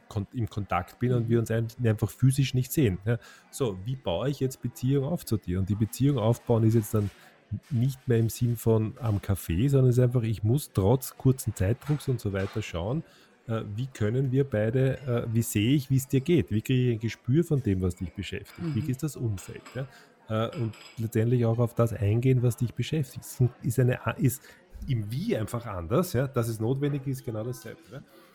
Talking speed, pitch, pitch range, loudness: 200 wpm, 120 Hz, 110-130 Hz, -28 LUFS